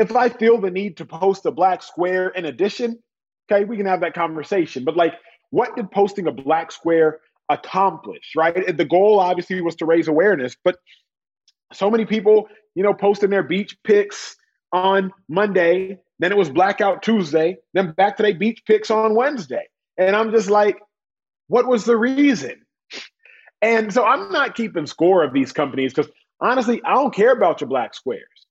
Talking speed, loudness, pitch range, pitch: 180 wpm, -19 LUFS, 170-220 Hz, 195 Hz